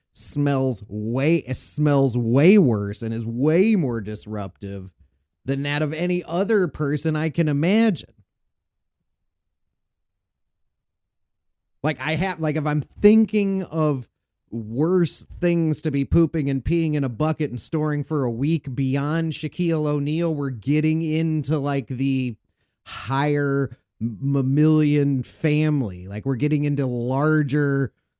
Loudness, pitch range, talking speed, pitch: -22 LUFS, 120-155 Hz, 125 wpm, 145 Hz